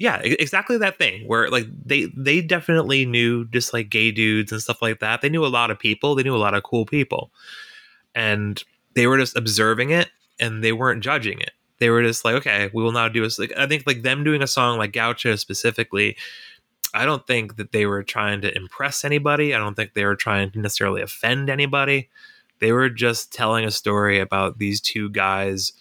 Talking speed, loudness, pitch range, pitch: 215 wpm, -20 LUFS, 105-135 Hz, 115 Hz